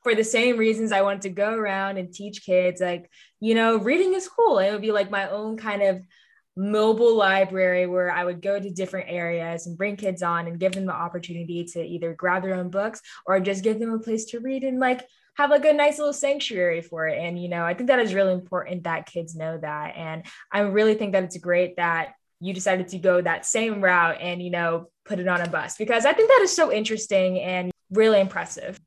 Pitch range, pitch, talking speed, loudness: 175-220 Hz, 195 Hz, 235 wpm, -23 LUFS